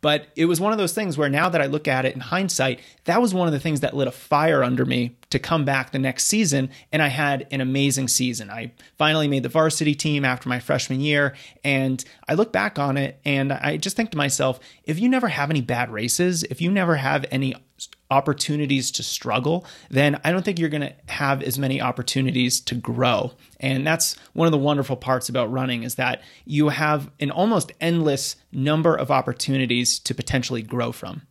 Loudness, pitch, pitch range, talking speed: -22 LUFS, 140 Hz, 130-155 Hz, 215 wpm